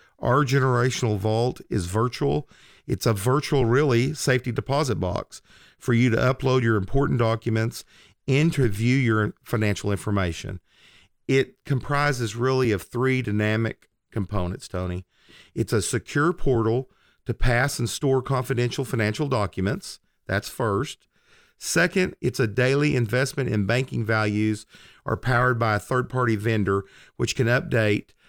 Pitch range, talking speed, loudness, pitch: 110-135 Hz, 130 wpm, -24 LUFS, 120 Hz